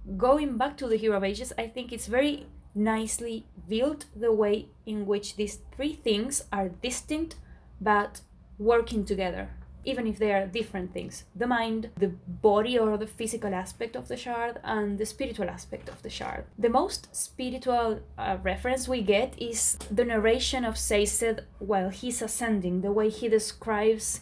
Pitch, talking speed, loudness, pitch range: 225 Hz, 170 wpm, -28 LUFS, 205-240 Hz